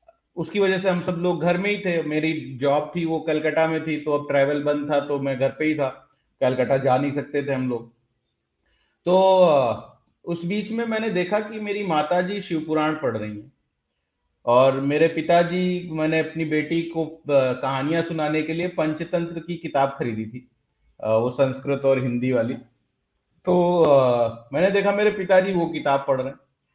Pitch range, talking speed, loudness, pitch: 135-175 Hz, 175 wpm, -22 LUFS, 155 Hz